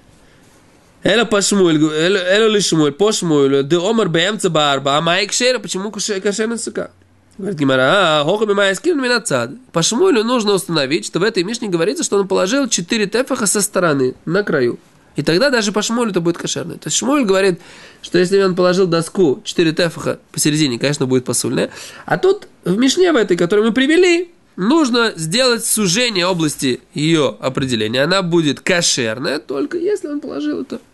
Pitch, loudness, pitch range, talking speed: 195 Hz, -16 LUFS, 165-230 Hz, 145 wpm